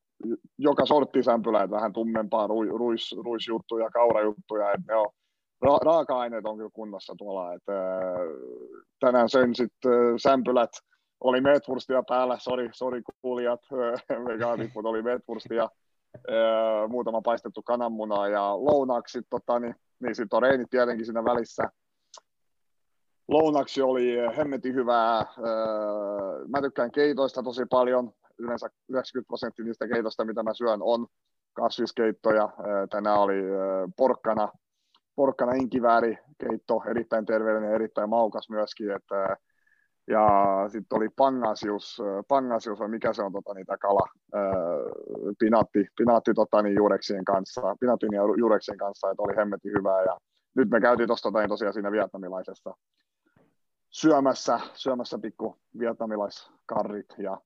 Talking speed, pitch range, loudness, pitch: 120 wpm, 105-125 Hz, -26 LUFS, 115 Hz